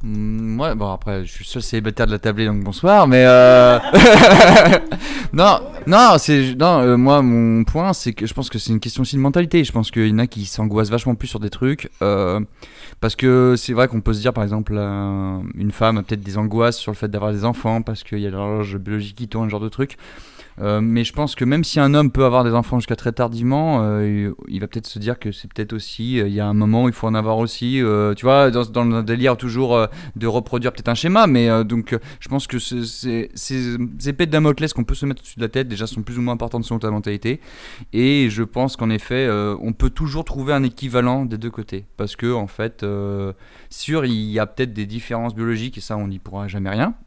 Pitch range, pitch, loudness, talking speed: 105-125 Hz, 115 Hz, -17 LUFS, 250 wpm